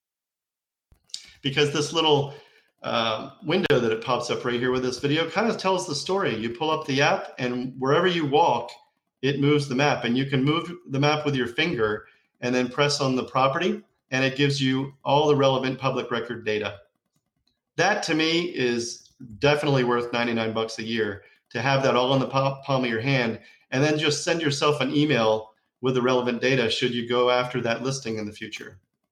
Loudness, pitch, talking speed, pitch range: -24 LUFS, 135 Hz, 200 wpm, 120-145 Hz